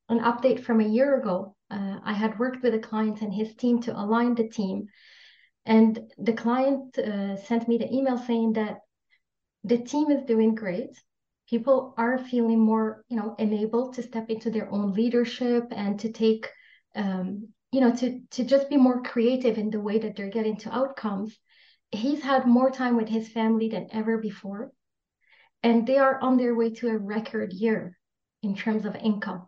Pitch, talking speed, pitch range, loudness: 225 Hz, 185 wpm, 215-245 Hz, -26 LUFS